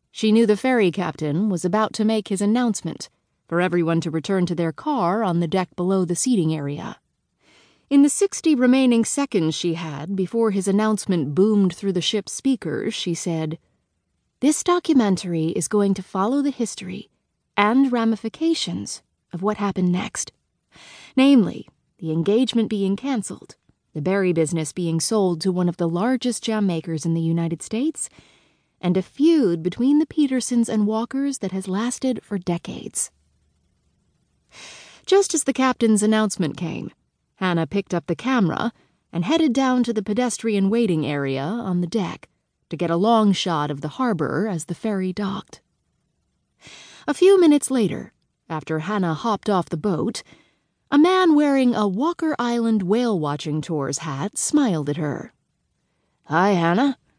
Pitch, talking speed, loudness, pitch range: 200 Hz, 155 wpm, -21 LUFS, 170-240 Hz